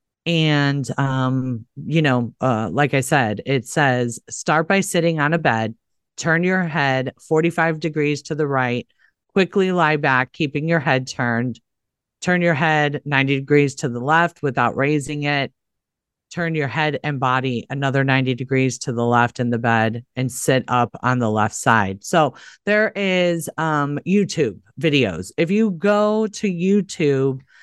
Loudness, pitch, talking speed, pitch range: -20 LUFS, 140 Hz, 160 wpm, 125-165 Hz